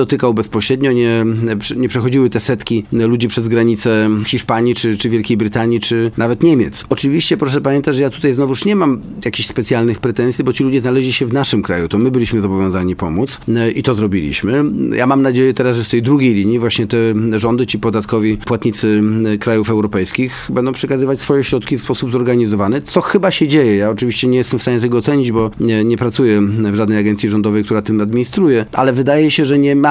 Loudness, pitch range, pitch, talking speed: -14 LUFS, 110-130 Hz, 120 Hz, 200 wpm